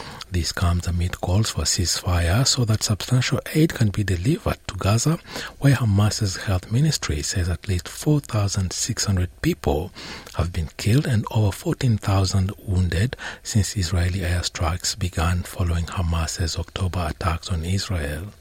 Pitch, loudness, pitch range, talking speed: 95 Hz, -23 LUFS, 90-110 Hz, 135 wpm